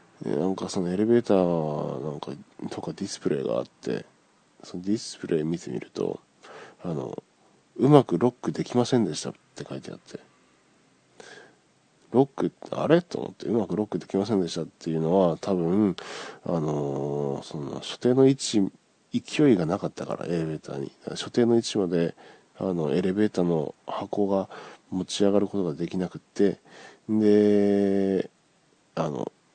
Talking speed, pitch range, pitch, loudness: 310 characters per minute, 85-105 Hz, 95 Hz, -26 LUFS